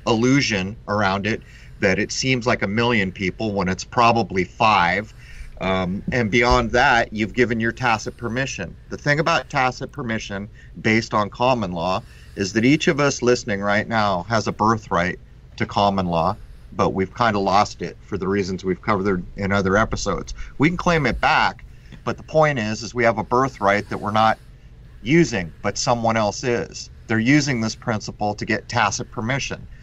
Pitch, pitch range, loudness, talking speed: 110 Hz, 100-125 Hz, -21 LUFS, 180 wpm